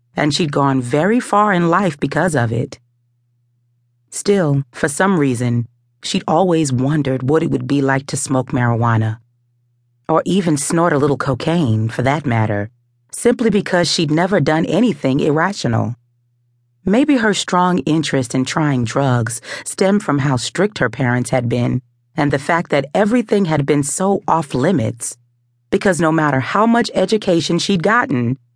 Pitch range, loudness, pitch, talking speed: 120-175 Hz, -16 LUFS, 140 Hz, 155 wpm